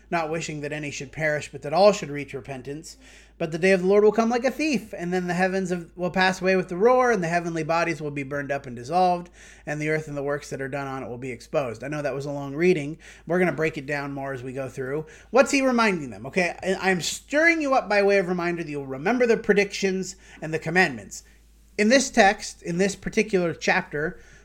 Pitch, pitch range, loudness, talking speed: 170 Hz, 145-195 Hz, -24 LUFS, 255 wpm